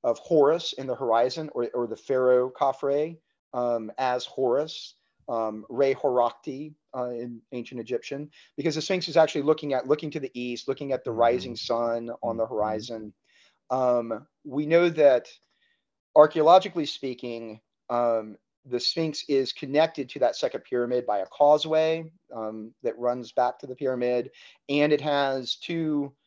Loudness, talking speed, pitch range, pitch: -26 LUFS, 155 wpm, 120-150 Hz, 130 Hz